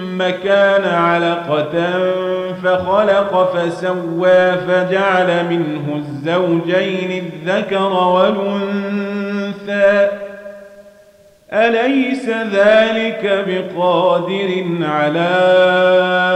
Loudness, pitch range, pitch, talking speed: -15 LUFS, 180-200 Hz, 185 Hz, 50 wpm